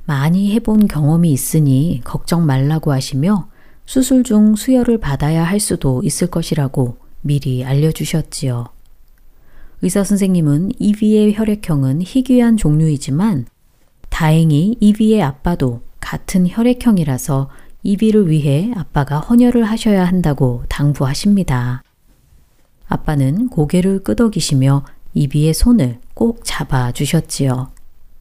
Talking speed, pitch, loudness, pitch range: 270 characters per minute, 155 Hz, -15 LUFS, 135-210 Hz